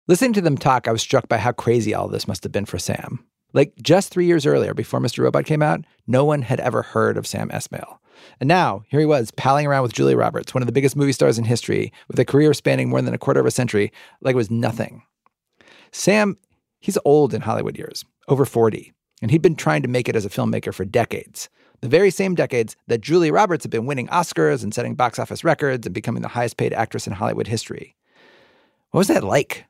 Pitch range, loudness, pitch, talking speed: 115-150 Hz, -20 LUFS, 130 Hz, 235 wpm